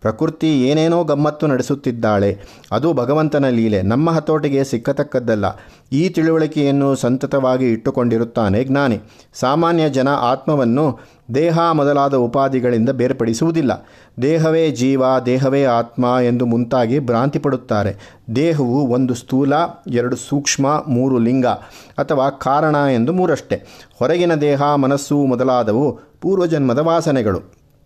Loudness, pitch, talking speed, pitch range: -17 LUFS, 135 Hz, 100 wpm, 120-150 Hz